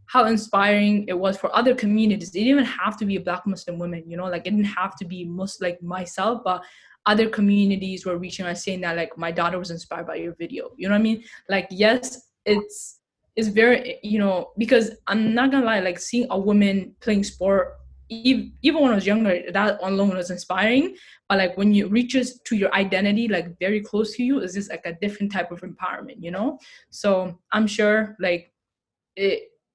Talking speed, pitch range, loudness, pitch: 210 wpm, 185-225 Hz, -22 LUFS, 200 Hz